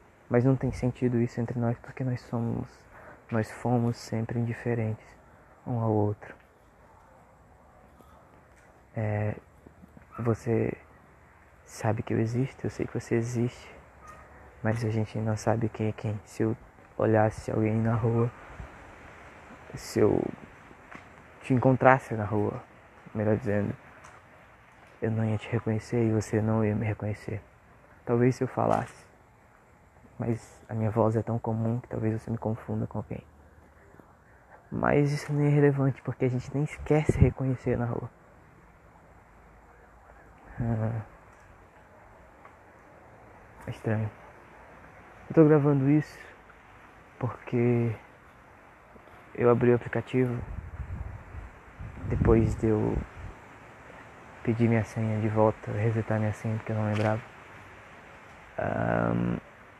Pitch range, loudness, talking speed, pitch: 105-120 Hz, -28 LUFS, 120 wpm, 110 Hz